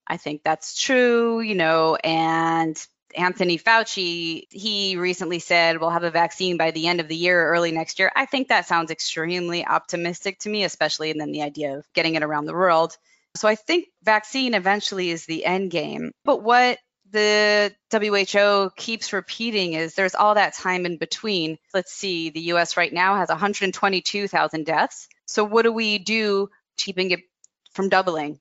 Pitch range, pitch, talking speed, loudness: 165-210 Hz, 185 Hz, 175 wpm, -21 LUFS